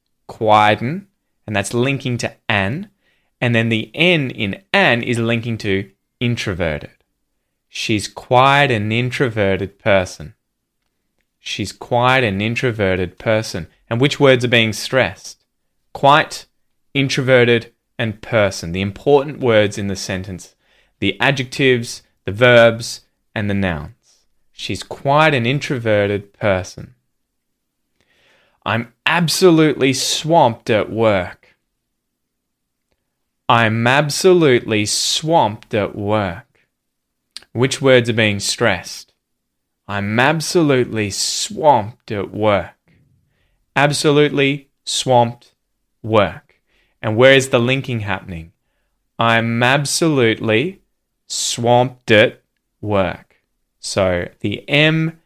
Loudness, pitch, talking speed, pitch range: -16 LUFS, 120 Hz, 100 wpm, 105-135 Hz